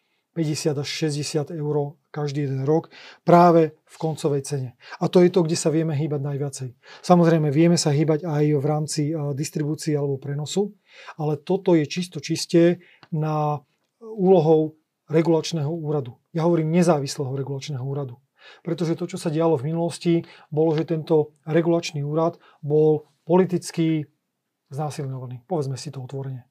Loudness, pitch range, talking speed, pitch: -23 LUFS, 145-170 Hz, 145 wpm, 155 Hz